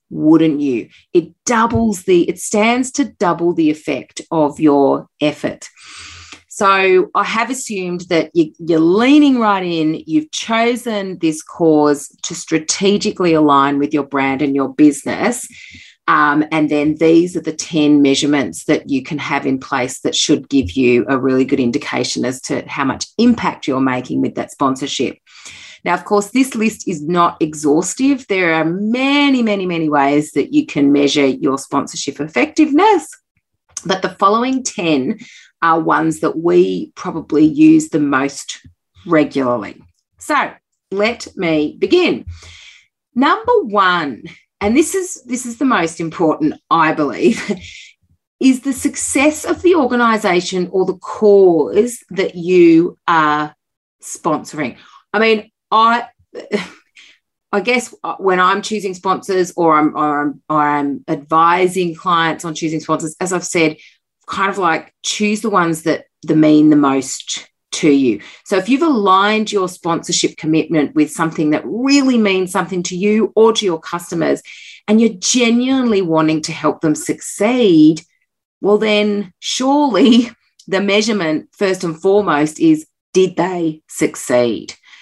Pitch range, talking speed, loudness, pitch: 155-225 Hz, 145 wpm, -15 LUFS, 180 Hz